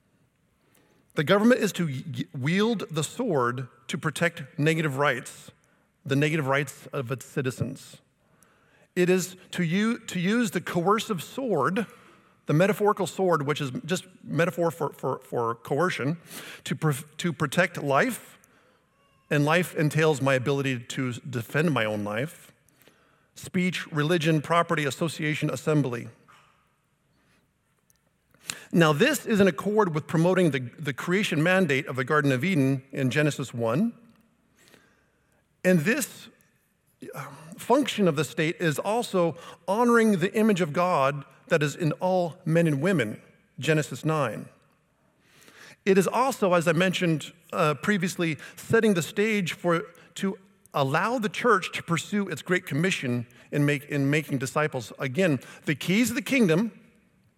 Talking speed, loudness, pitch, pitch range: 135 wpm, -26 LUFS, 165 Hz, 145-190 Hz